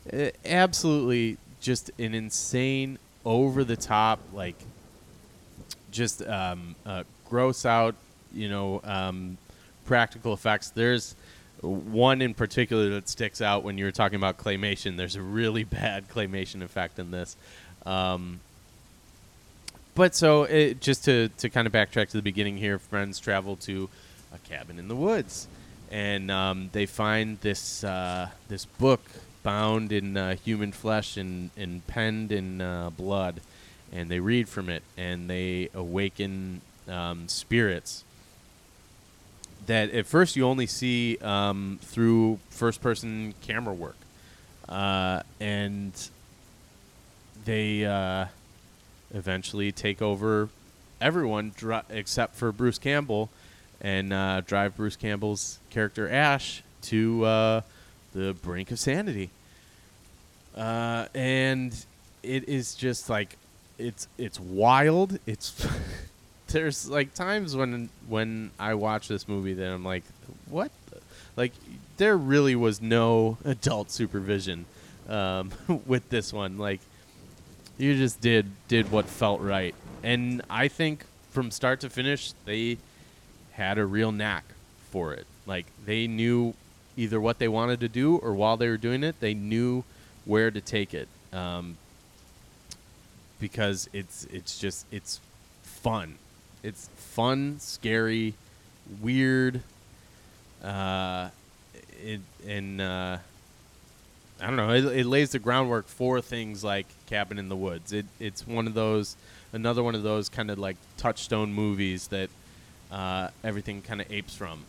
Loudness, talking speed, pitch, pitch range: -28 LUFS, 130 wpm, 105 Hz, 95-115 Hz